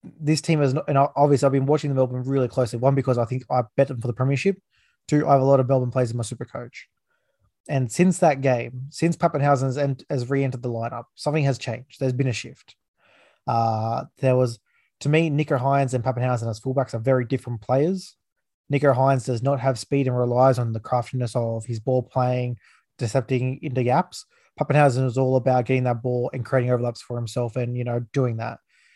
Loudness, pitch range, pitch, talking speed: -23 LUFS, 125-140 Hz, 130 Hz, 210 wpm